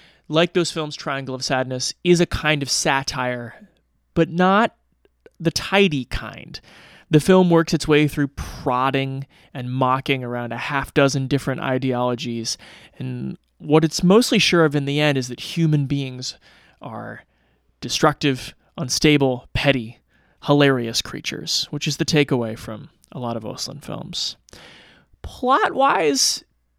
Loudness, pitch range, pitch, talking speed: -20 LUFS, 125-160 Hz, 140 Hz, 140 wpm